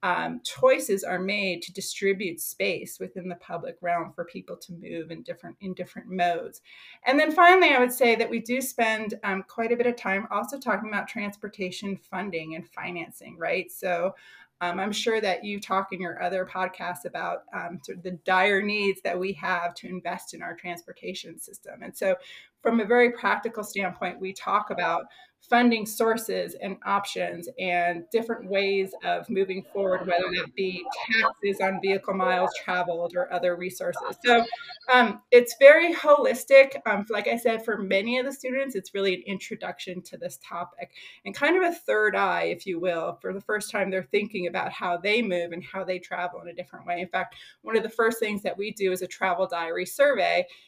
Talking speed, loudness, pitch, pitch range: 195 wpm, -25 LUFS, 195 Hz, 180-230 Hz